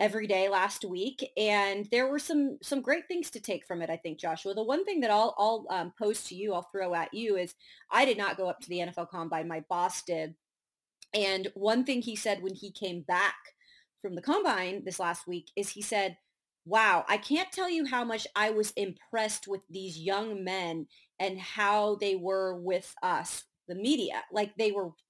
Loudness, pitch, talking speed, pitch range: -31 LUFS, 200 Hz, 210 wpm, 180-220 Hz